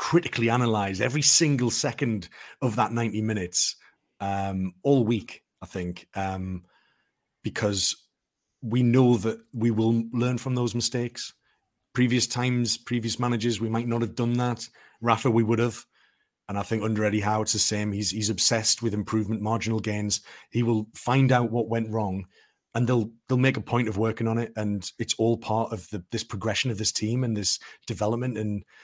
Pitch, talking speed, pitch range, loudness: 115 Hz, 180 wpm, 105-120 Hz, -25 LUFS